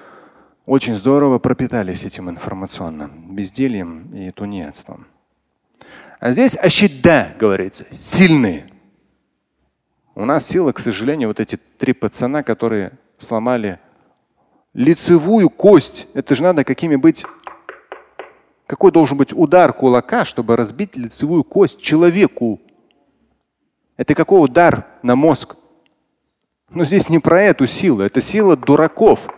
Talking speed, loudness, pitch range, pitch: 110 wpm, -14 LUFS, 110-170 Hz, 135 Hz